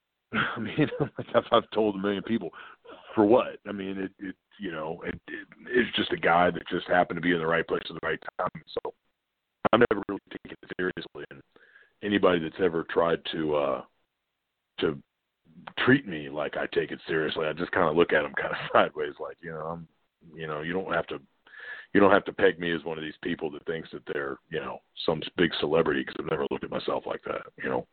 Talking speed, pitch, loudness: 230 wpm, 95 Hz, -28 LUFS